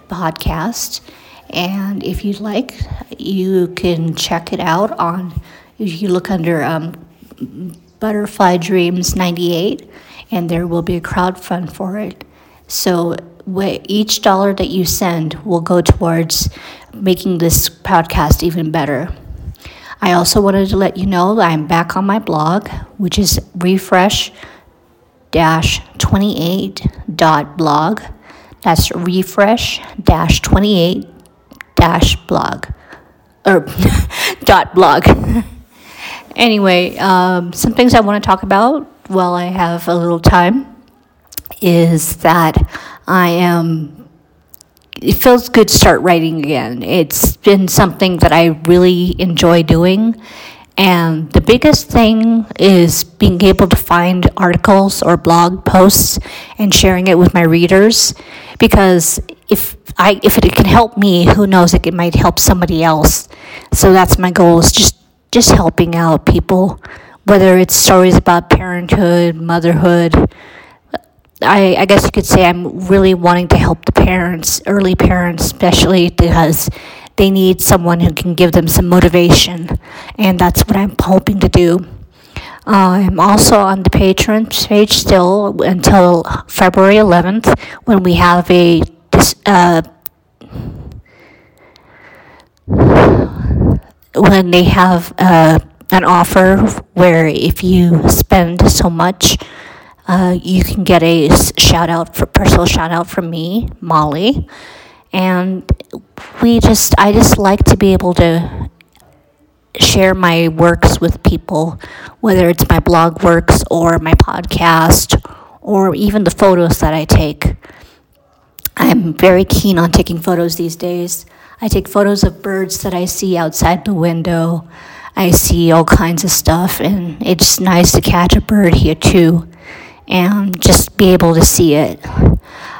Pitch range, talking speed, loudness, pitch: 170-195 Hz, 135 wpm, -11 LUFS, 180 Hz